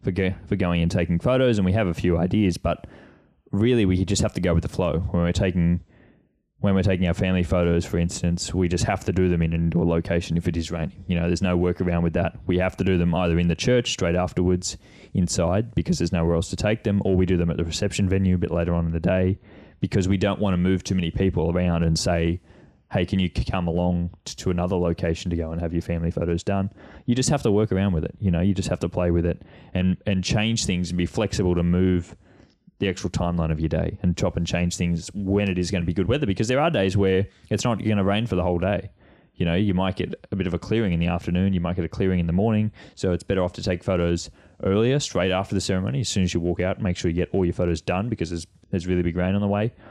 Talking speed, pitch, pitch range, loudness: 280 wpm, 90 Hz, 85-100 Hz, -23 LUFS